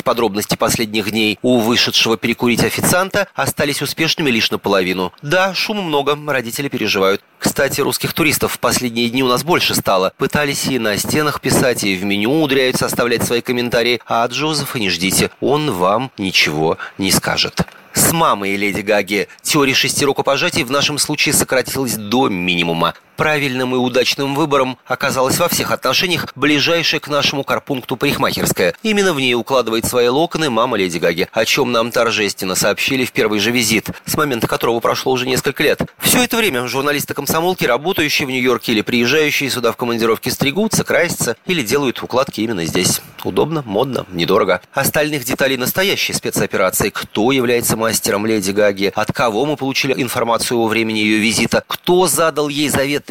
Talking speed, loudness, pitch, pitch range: 160 wpm, -16 LUFS, 130 Hz, 115-145 Hz